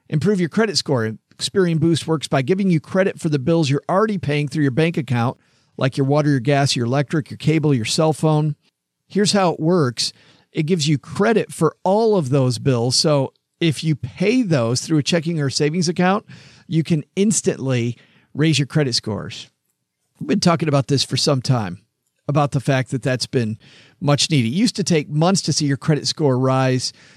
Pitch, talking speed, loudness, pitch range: 150 Hz, 200 wpm, -19 LUFS, 135-170 Hz